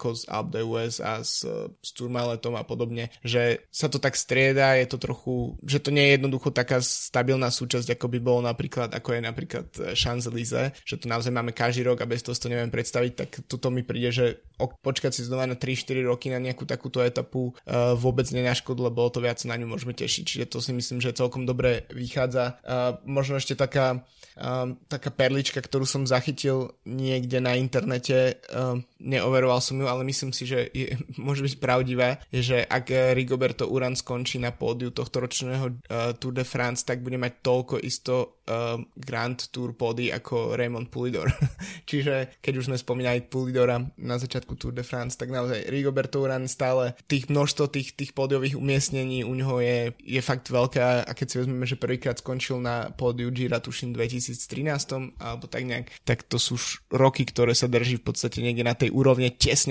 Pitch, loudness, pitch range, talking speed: 125 Hz, -26 LUFS, 120-130 Hz, 185 wpm